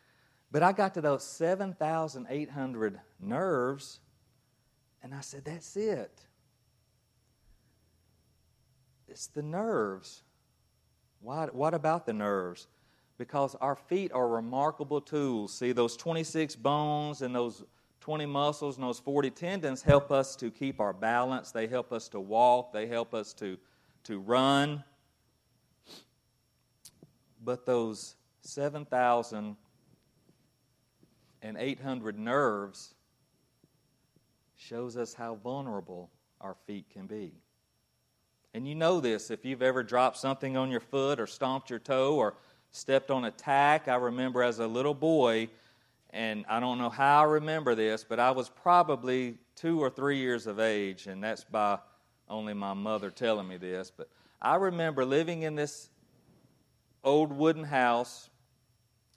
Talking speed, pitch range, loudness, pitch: 135 wpm, 115-140 Hz, -31 LUFS, 125 Hz